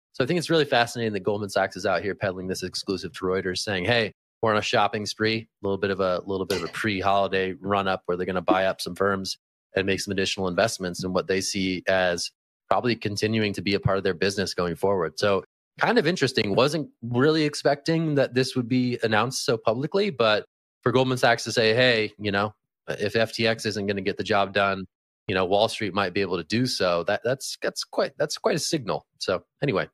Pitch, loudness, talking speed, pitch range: 105 Hz, -25 LUFS, 225 wpm, 95-120 Hz